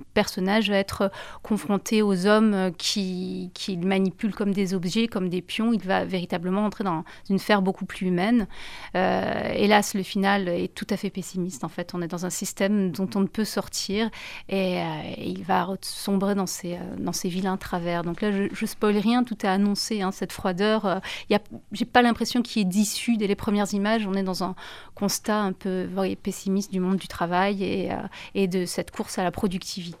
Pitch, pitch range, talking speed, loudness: 195 Hz, 185-210 Hz, 205 wpm, -25 LUFS